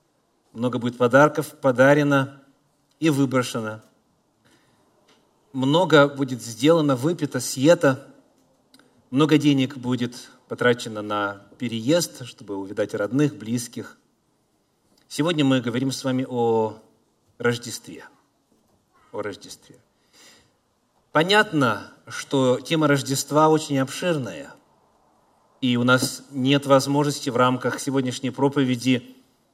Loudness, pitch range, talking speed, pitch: -22 LUFS, 125-145 Hz, 90 wpm, 130 Hz